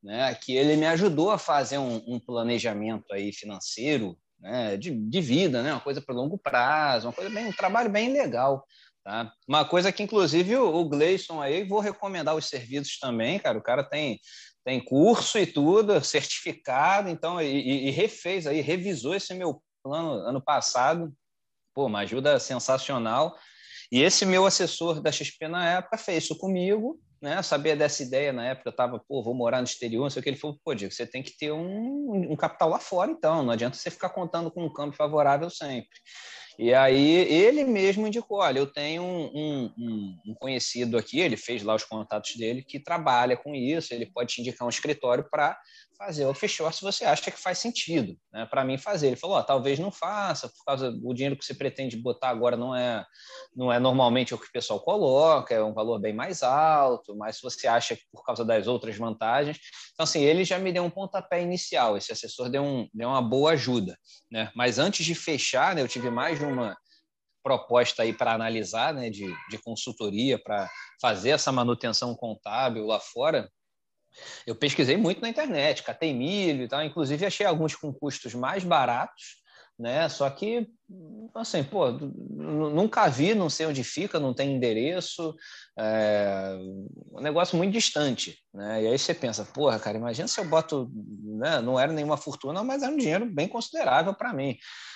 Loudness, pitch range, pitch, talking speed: -27 LUFS, 120-180 Hz, 145 Hz, 195 wpm